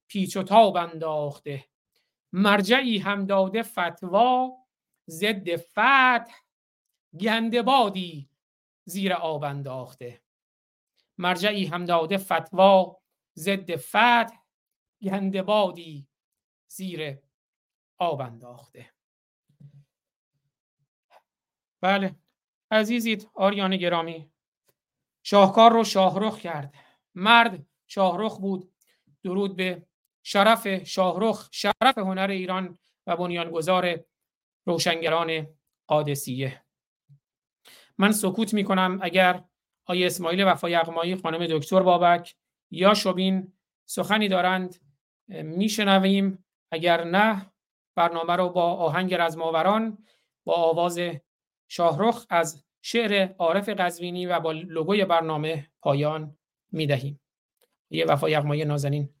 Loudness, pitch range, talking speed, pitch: -24 LUFS, 160-195 Hz, 85 wpm, 180 Hz